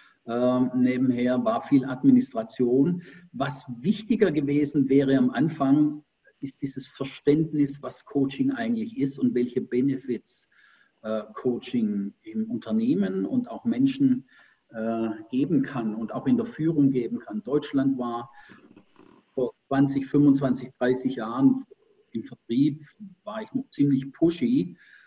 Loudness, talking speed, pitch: -25 LUFS, 125 wpm, 140 Hz